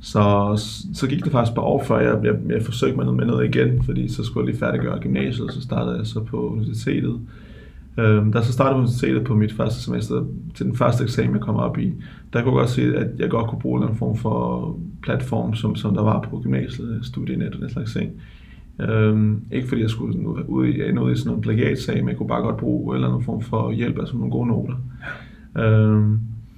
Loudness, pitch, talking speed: -22 LUFS, 105 Hz, 235 wpm